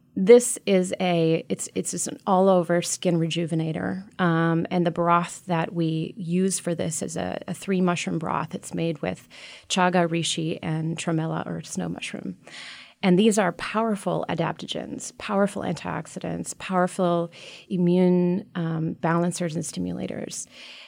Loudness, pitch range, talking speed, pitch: -25 LUFS, 165-185 Hz, 140 wpm, 175 Hz